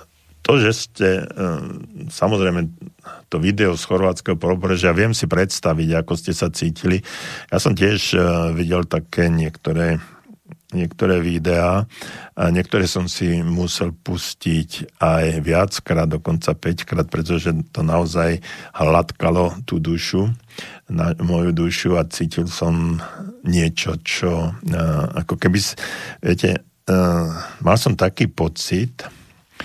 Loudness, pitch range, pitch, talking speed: -20 LUFS, 85-95 Hz, 85 Hz, 110 wpm